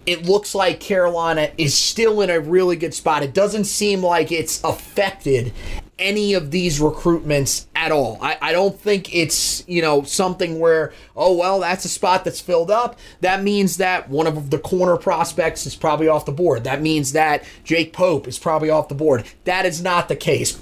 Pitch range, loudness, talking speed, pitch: 155-185 Hz, -19 LUFS, 200 wpm, 170 Hz